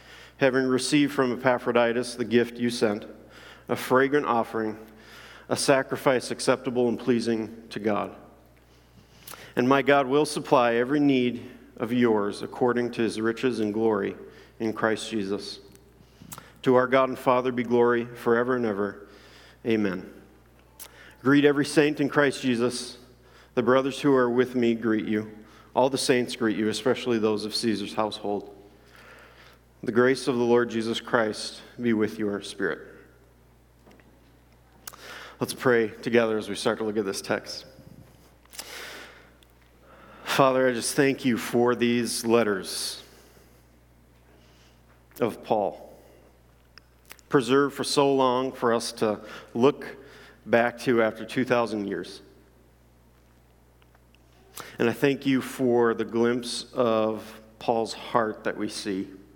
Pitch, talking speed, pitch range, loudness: 115 Hz, 130 wpm, 100-125 Hz, -25 LUFS